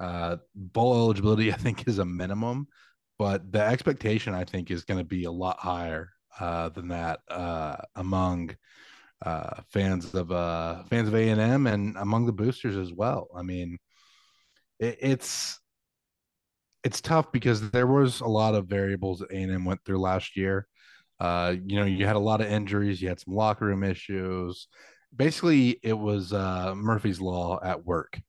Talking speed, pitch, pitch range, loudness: 170 wpm, 100 Hz, 90-110 Hz, -28 LUFS